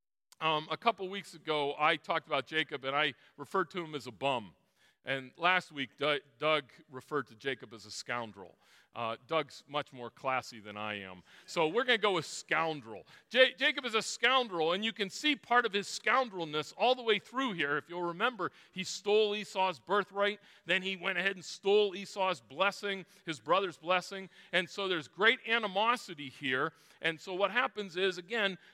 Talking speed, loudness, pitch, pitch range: 190 wpm, -33 LUFS, 180 Hz, 145-200 Hz